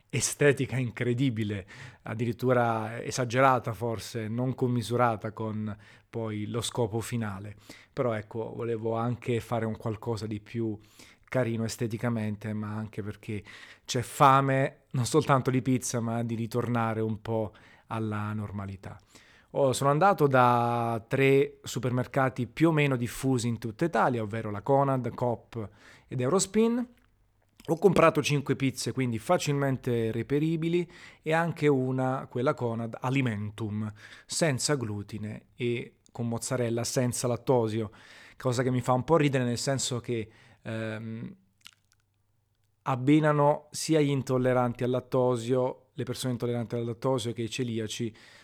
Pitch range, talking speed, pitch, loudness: 110-130 Hz, 130 wpm, 120 Hz, -28 LUFS